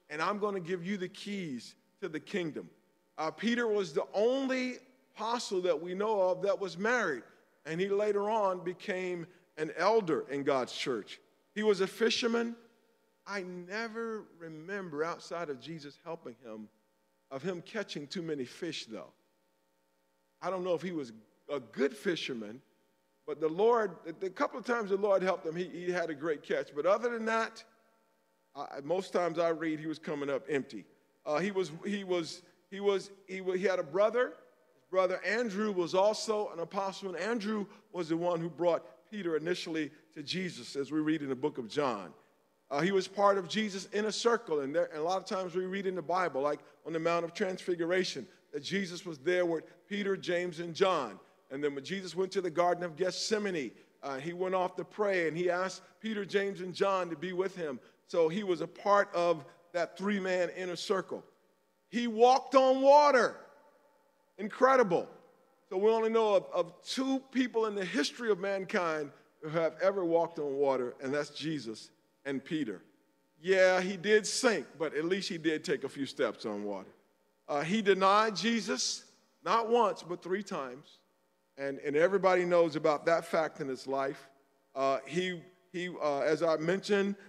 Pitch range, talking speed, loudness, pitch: 160-205 Hz, 190 wpm, -32 LUFS, 185 Hz